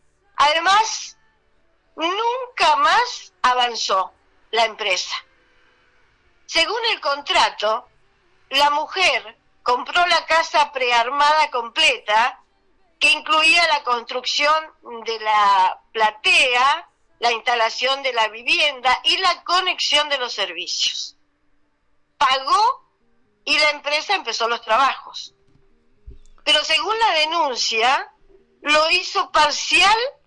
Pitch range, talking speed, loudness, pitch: 245-360 Hz, 95 wpm, -18 LUFS, 300 Hz